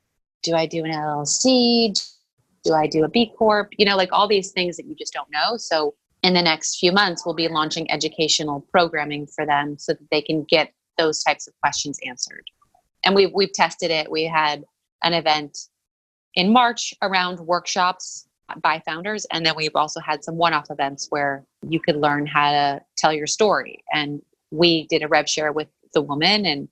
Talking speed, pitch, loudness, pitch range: 200 wpm, 160 Hz, -20 LUFS, 150-185 Hz